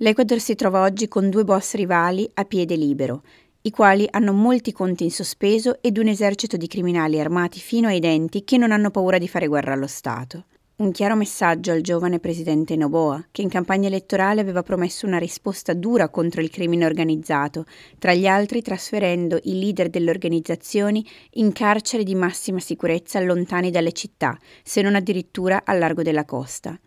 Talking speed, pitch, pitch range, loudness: 175 wpm, 185 Hz, 165-205 Hz, -21 LUFS